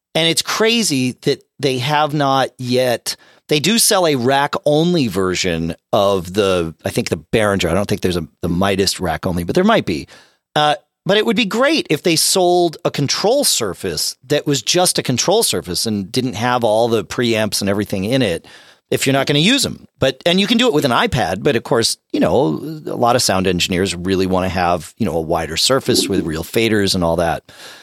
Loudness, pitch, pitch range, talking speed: -16 LUFS, 125 Hz, 95-150 Hz, 220 wpm